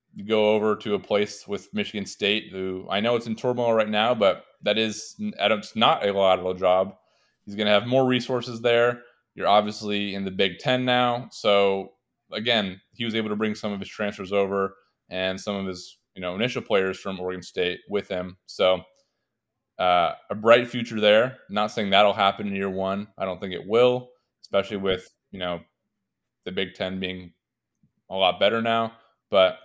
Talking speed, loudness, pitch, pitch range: 195 wpm, -24 LUFS, 100 Hz, 95-115 Hz